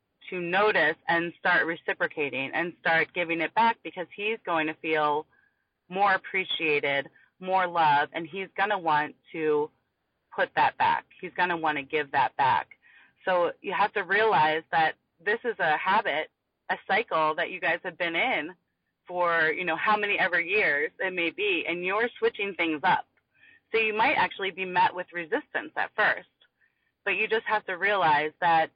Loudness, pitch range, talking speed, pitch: -26 LUFS, 160-215 Hz, 180 wpm, 180 Hz